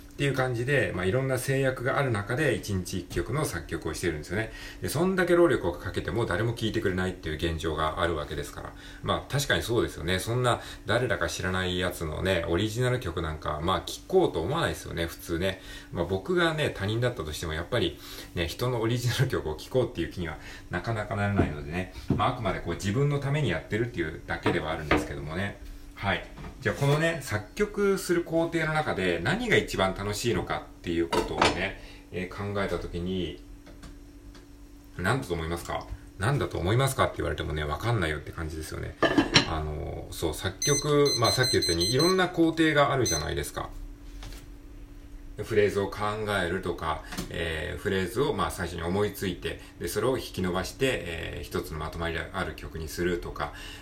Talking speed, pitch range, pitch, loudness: 415 characters per minute, 85-115 Hz, 95 Hz, -28 LUFS